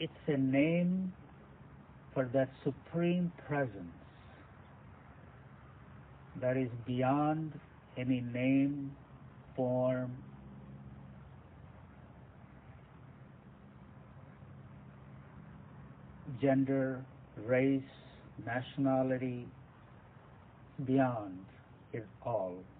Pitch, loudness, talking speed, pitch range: 130 Hz, -35 LUFS, 50 wpm, 95-140 Hz